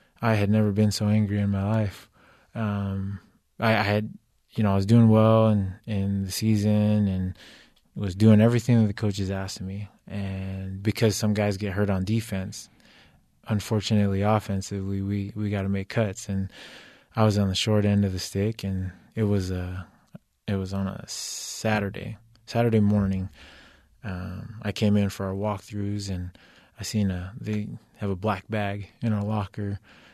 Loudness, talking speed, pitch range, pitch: -26 LUFS, 175 wpm, 95-110 Hz, 105 Hz